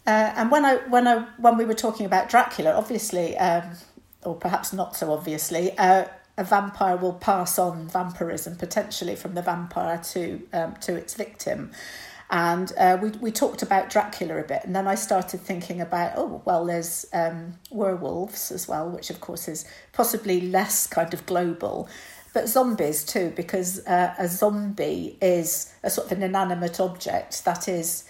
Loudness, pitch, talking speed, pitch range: -25 LUFS, 185 Hz, 175 wpm, 175-210 Hz